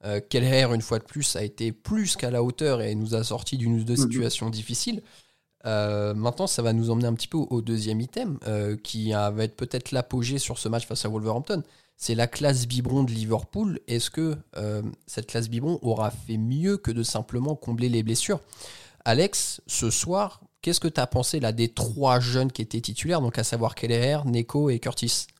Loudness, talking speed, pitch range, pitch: -26 LUFS, 210 wpm, 115-130 Hz, 120 Hz